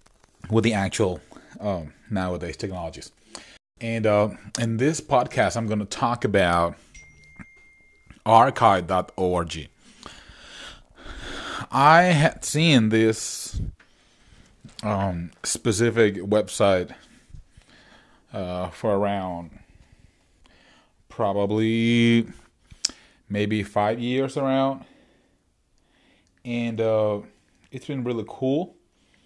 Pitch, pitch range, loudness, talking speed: 105 Hz, 90-115 Hz, -23 LUFS, 80 wpm